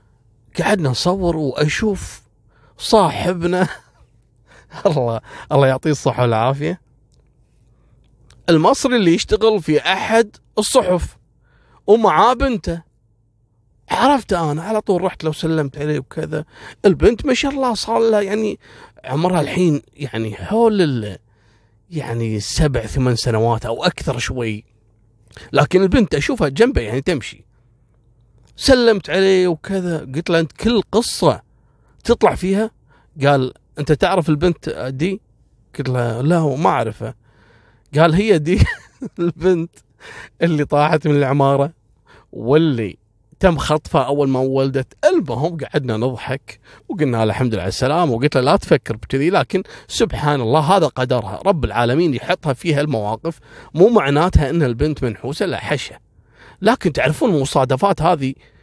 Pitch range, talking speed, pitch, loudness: 120-180 Hz, 125 wpm, 145 Hz, -17 LUFS